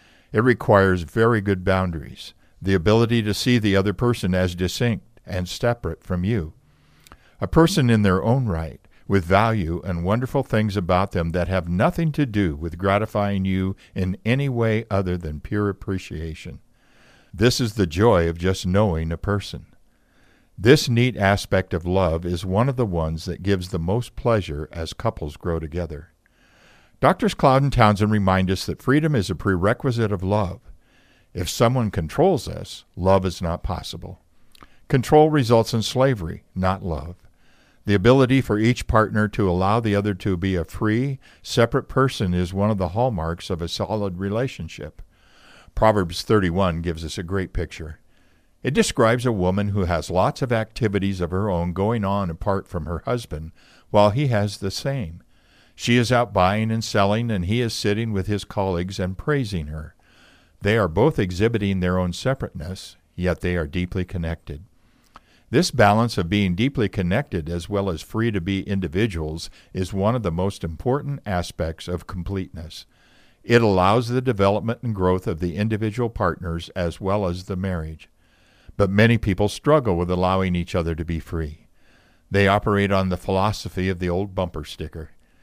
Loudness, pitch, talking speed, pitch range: -22 LUFS, 95 Hz, 170 wpm, 90-110 Hz